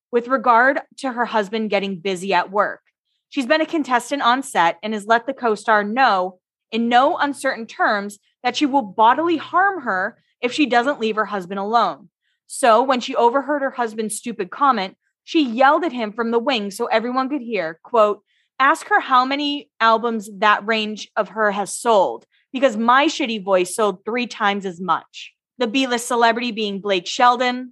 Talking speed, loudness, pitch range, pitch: 180 wpm, -19 LUFS, 210-270 Hz, 235 Hz